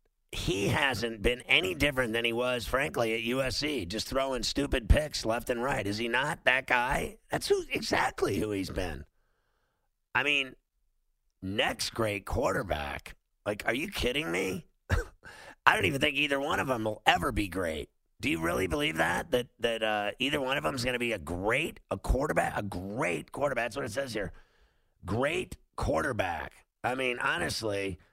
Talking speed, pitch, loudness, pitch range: 175 wpm, 120 Hz, -30 LUFS, 105-135 Hz